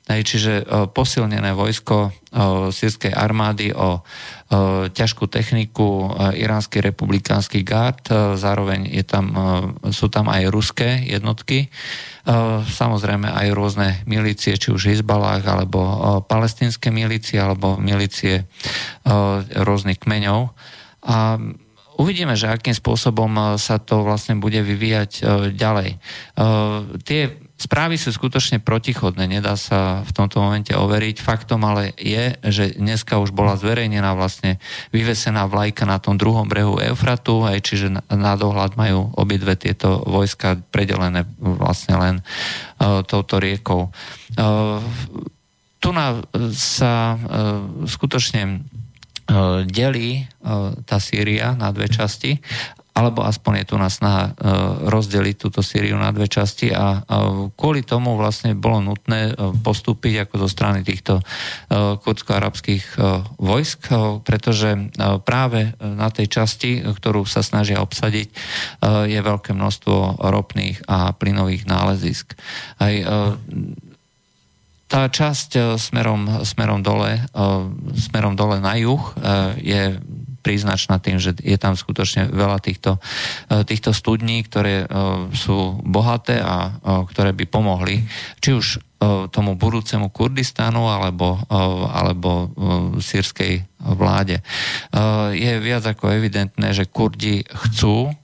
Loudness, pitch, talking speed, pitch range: -19 LUFS, 105 Hz, 110 wpm, 100-115 Hz